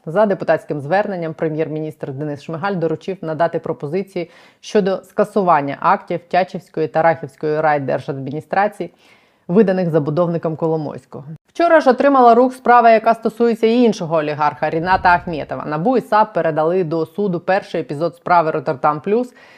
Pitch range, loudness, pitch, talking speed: 160-205 Hz, -17 LUFS, 170 Hz, 130 wpm